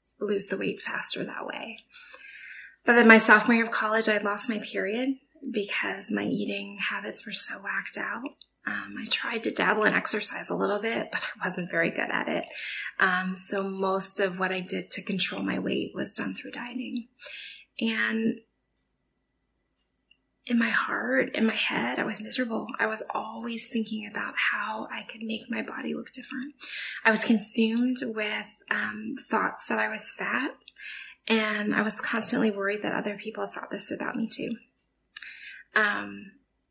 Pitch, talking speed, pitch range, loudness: 225 Hz, 170 wpm, 205-240 Hz, -27 LUFS